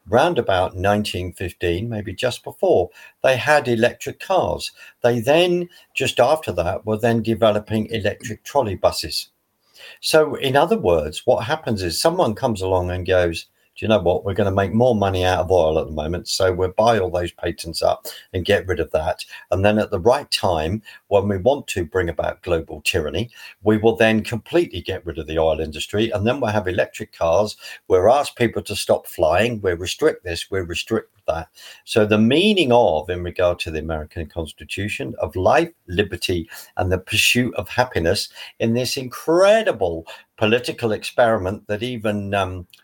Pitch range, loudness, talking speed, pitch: 90-120 Hz, -20 LUFS, 185 wpm, 105 Hz